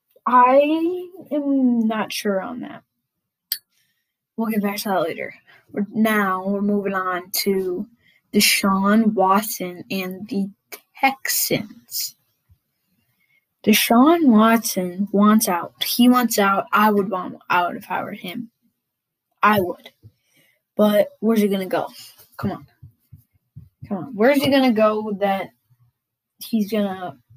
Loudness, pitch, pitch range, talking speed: -19 LUFS, 205 Hz, 185-230 Hz, 125 wpm